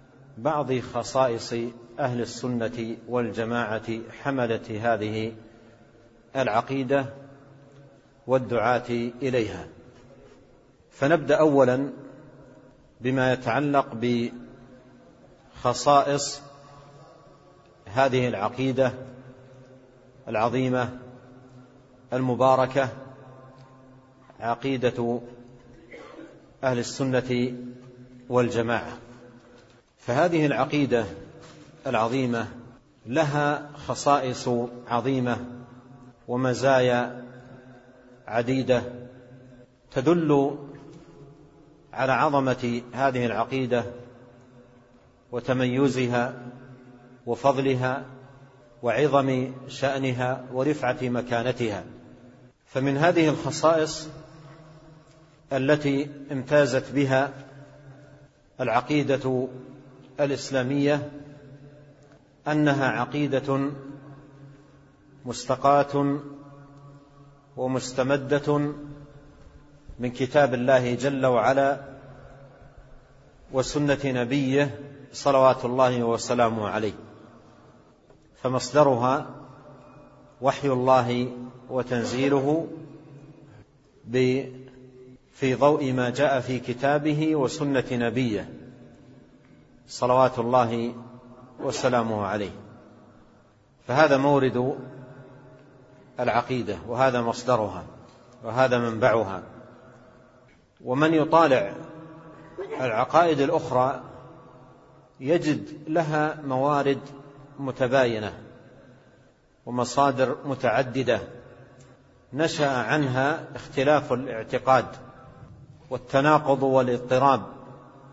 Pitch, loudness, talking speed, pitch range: 130 Hz, -25 LUFS, 55 wpm, 125-140 Hz